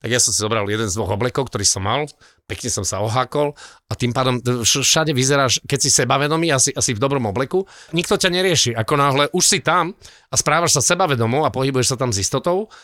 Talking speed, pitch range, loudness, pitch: 220 wpm, 120-155 Hz, -18 LUFS, 135 Hz